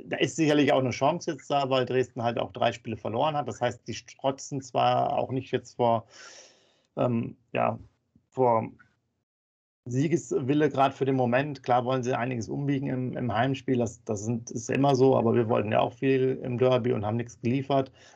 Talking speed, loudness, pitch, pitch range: 195 wpm, -27 LUFS, 125 Hz, 120-135 Hz